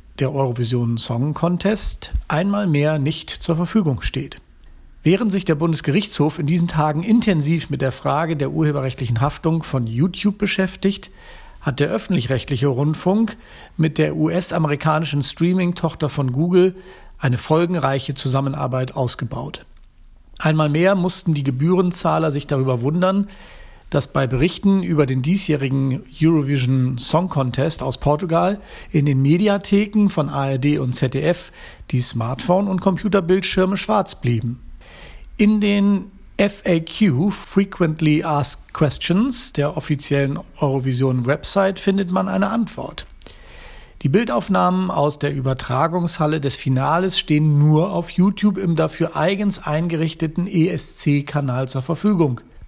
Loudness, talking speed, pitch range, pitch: -19 LUFS, 120 wpm, 135-185 Hz, 155 Hz